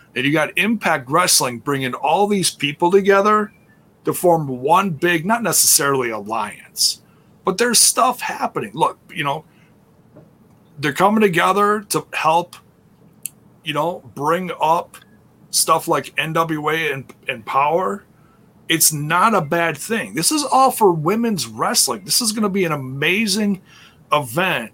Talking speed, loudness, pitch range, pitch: 140 wpm, -17 LUFS, 155-210 Hz, 175 Hz